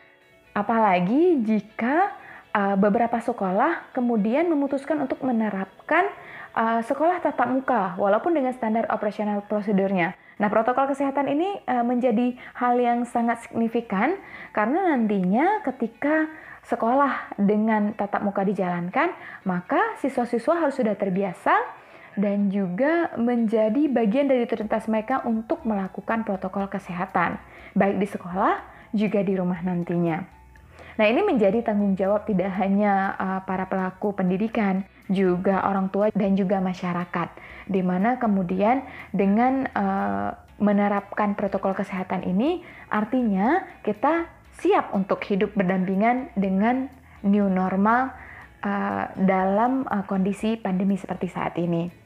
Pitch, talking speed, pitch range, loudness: 215 Hz, 115 wpm, 195-250 Hz, -24 LUFS